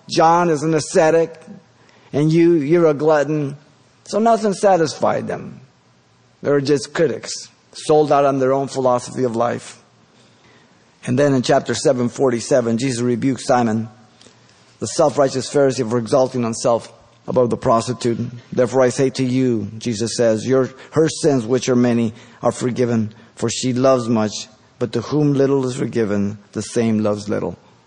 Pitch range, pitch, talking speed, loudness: 115-145 Hz, 125 Hz, 155 wpm, -18 LUFS